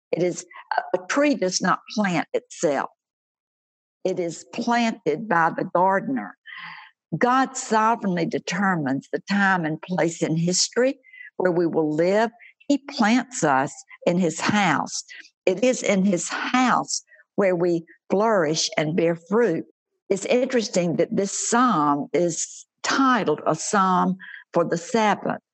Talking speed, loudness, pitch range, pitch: 130 wpm, -23 LUFS, 170-245 Hz, 195 Hz